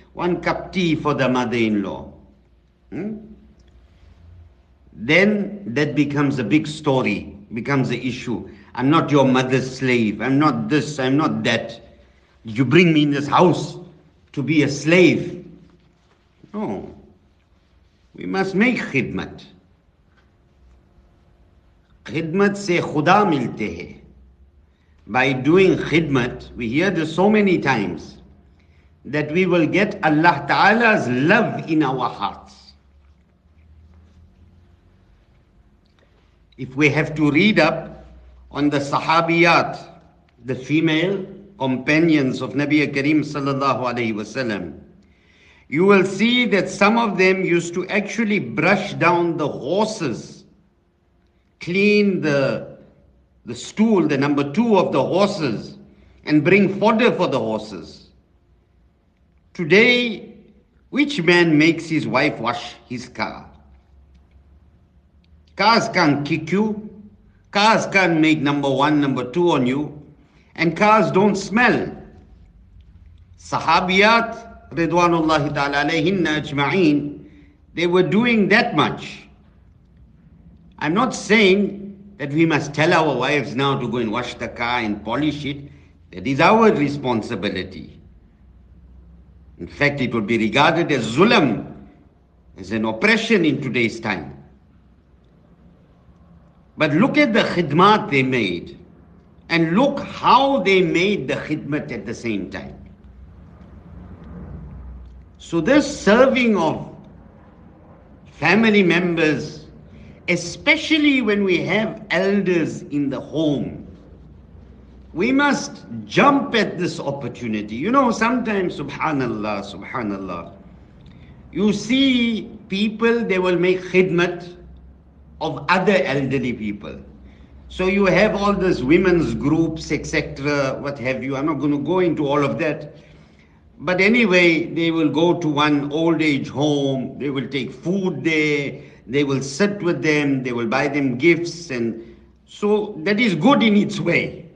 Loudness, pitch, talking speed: -18 LUFS, 145 Hz, 120 wpm